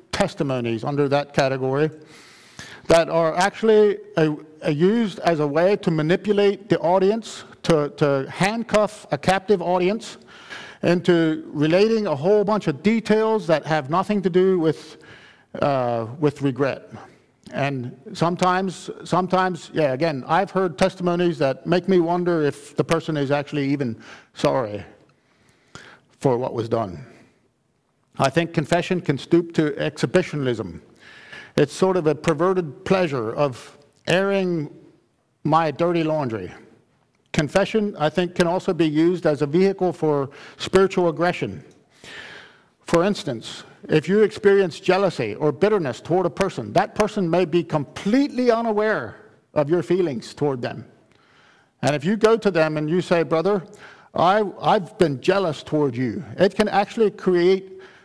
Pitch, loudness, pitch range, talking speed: 170 Hz, -21 LUFS, 150-190 Hz, 140 wpm